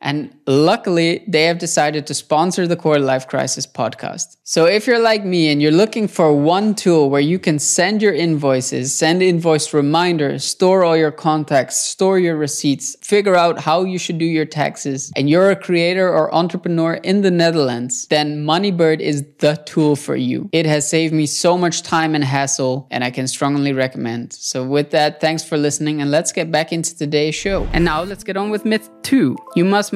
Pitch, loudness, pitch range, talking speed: 160 Hz, -16 LUFS, 145-175 Hz, 200 wpm